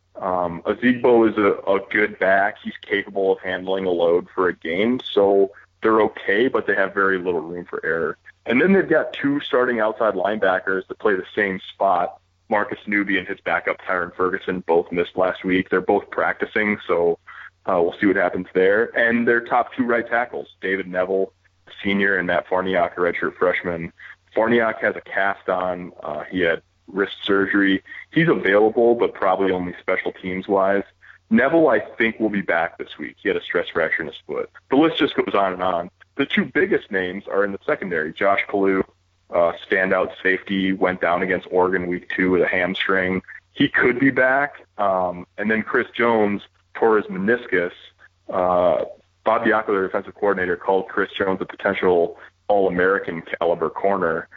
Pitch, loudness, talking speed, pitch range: 95 Hz, -21 LUFS, 180 wpm, 90-110 Hz